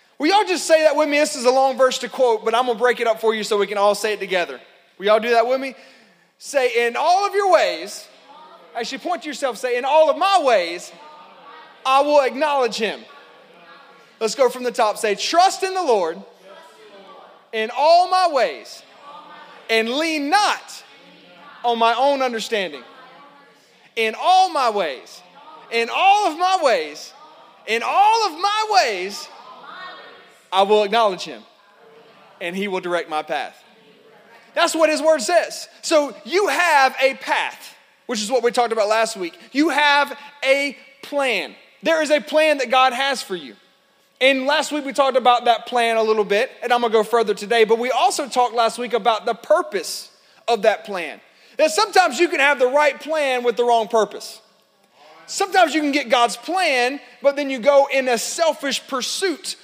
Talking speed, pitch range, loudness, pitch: 195 wpm, 230-310 Hz, -19 LUFS, 260 Hz